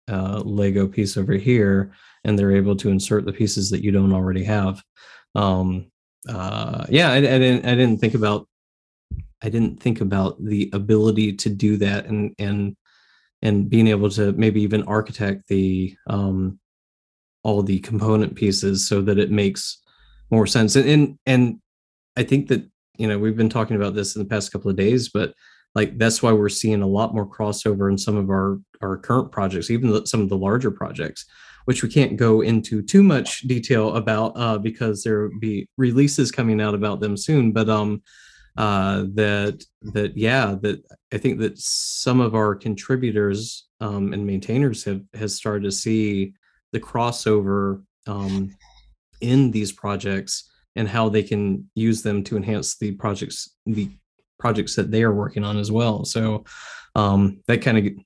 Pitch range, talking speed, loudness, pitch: 100-110 Hz, 180 wpm, -21 LUFS, 105 Hz